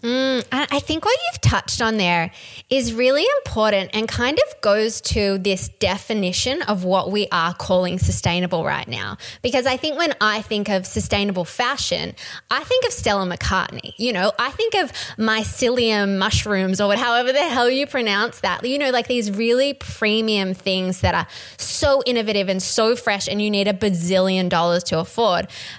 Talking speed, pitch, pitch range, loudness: 175 wpm, 215 Hz, 190-255 Hz, -18 LUFS